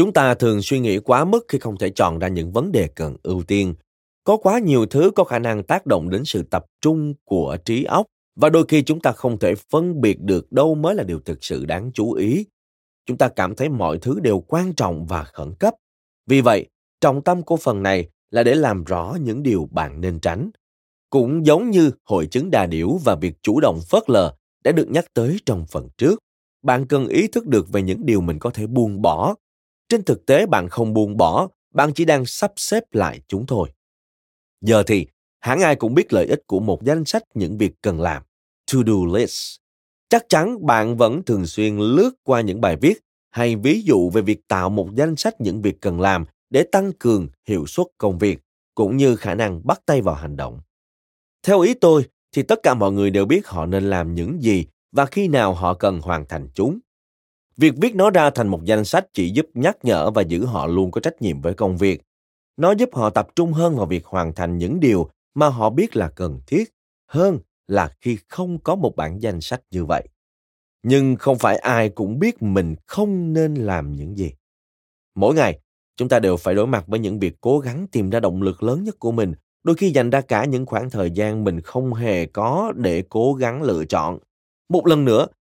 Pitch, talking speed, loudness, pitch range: 105 Hz, 220 wpm, -19 LUFS, 85-140 Hz